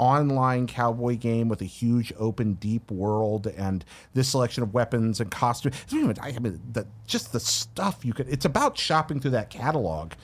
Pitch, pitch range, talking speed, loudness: 120 Hz, 110-130 Hz, 190 wpm, -26 LUFS